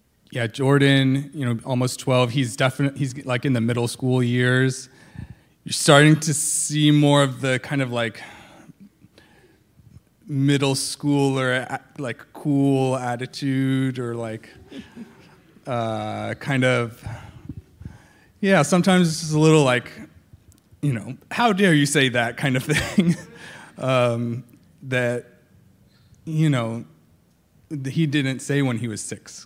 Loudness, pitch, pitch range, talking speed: -21 LUFS, 135 Hz, 120-145 Hz, 130 wpm